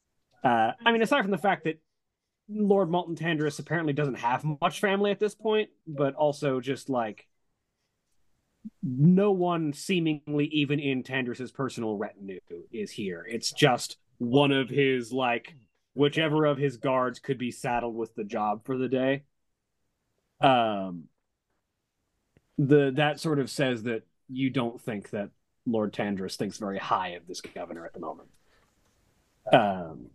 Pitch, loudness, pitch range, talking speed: 140 Hz, -27 LUFS, 120-155 Hz, 150 wpm